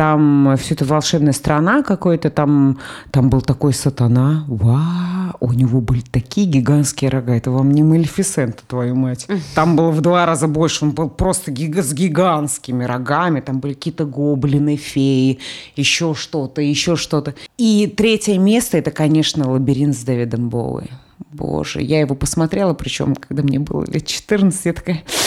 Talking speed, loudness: 160 wpm, -17 LUFS